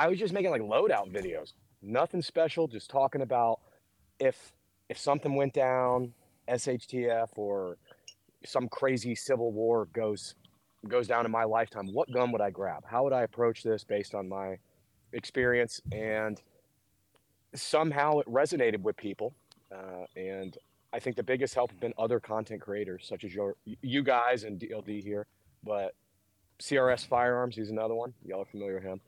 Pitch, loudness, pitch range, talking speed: 115 Hz, -31 LUFS, 100-125 Hz, 165 wpm